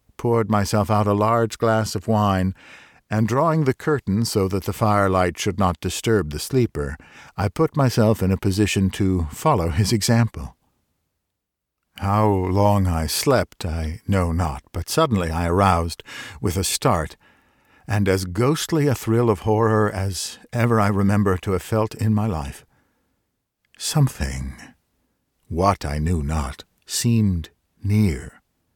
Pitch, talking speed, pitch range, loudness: 100 Hz, 145 wpm, 90-110 Hz, -21 LUFS